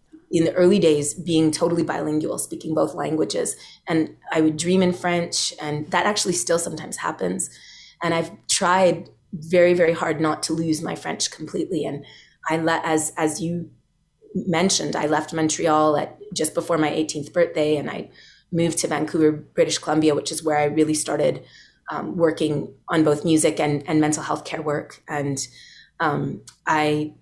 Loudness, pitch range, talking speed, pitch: -22 LUFS, 155-170 Hz, 170 wpm, 160 Hz